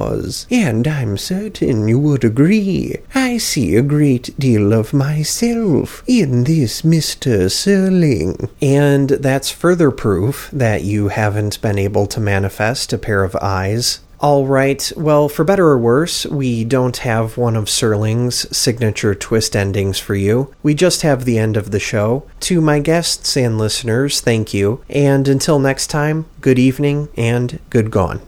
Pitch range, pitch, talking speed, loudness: 110-150 Hz, 130 Hz, 155 wpm, -15 LUFS